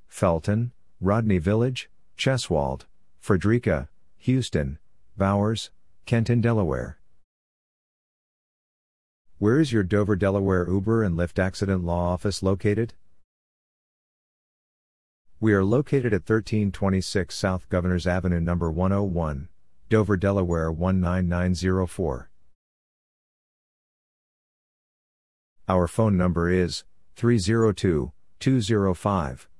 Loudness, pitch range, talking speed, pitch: -24 LUFS, 85-105 Hz, 80 wpm, 95 Hz